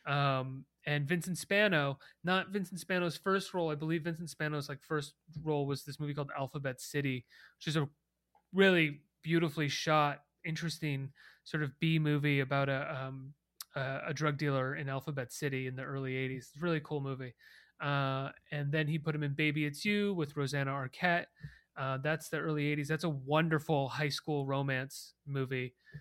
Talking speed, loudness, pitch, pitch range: 180 wpm, -35 LUFS, 150 Hz, 140-160 Hz